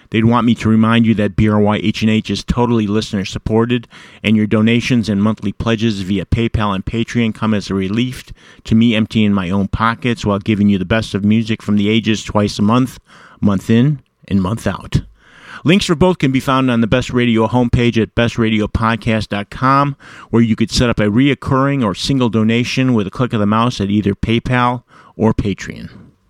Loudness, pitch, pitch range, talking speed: -15 LUFS, 110 Hz, 105-120 Hz, 190 wpm